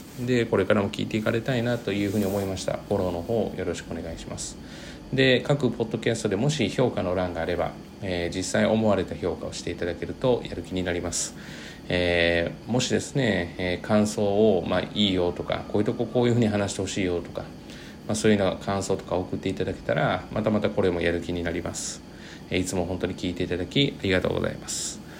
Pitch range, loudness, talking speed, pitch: 90-110 Hz, -26 LUFS, 450 characters per minute, 95 Hz